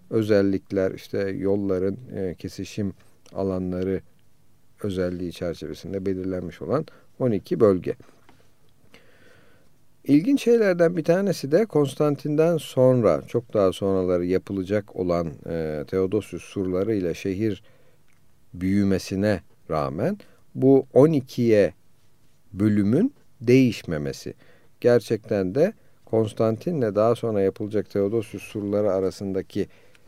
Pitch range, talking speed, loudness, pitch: 95-120 Hz, 90 wpm, -24 LUFS, 100 Hz